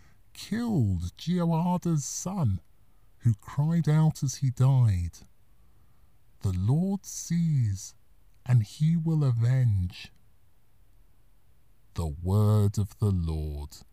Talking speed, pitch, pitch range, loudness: 90 wpm, 110 Hz, 100-145 Hz, -27 LUFS